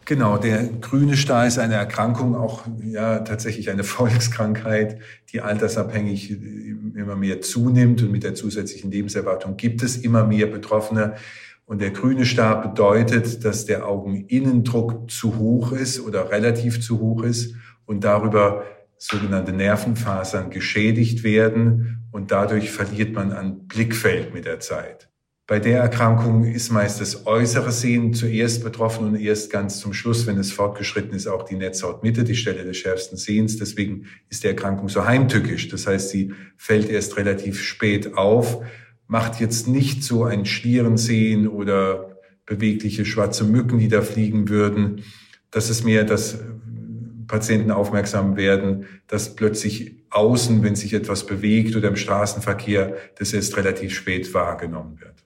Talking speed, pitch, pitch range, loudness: 150 wpm, 110 Hz, 100-115 Hz, -21 LUFS